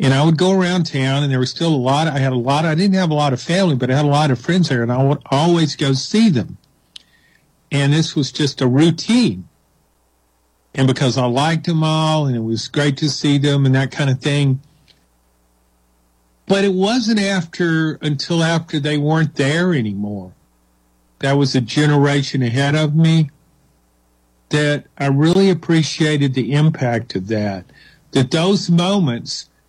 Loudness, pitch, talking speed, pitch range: -17 LUFS, 145 Hz, 180 wpm, 125-160 Hz